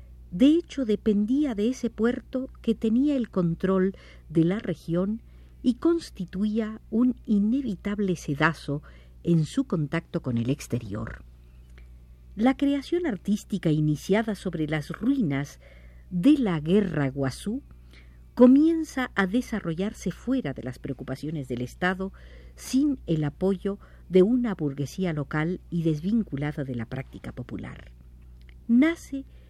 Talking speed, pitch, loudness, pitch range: 120 wpm, 185 Hz, -26 LUFS, 140-230 Hz